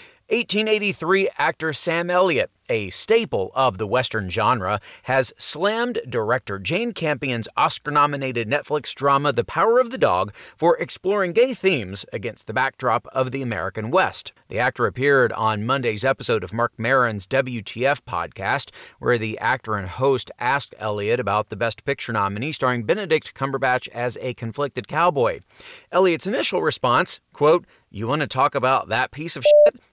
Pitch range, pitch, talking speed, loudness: 115-180 Hz, 135 Hz, 155 wpm, -21 LUFS